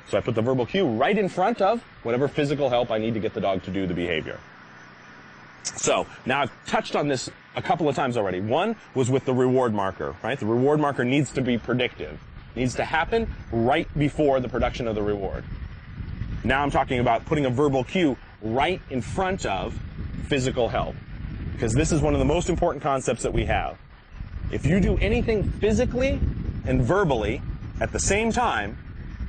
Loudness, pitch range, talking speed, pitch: -24 LUFS, 110-150 Hz, 195 wpm, 130 Hz